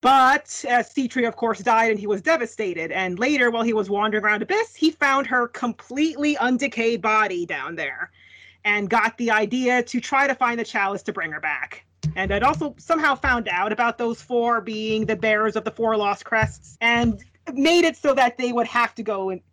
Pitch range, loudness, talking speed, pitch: 215-260 Hz, -21 LUFS, 210 wpm, 230 Hz